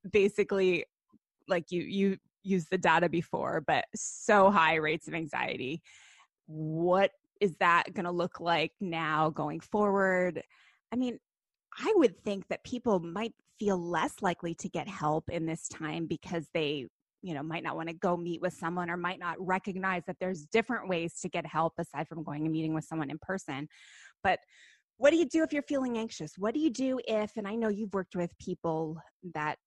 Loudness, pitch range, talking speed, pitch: -31 LUFS, 160-200 Hz, 190 wpm, 180 Hz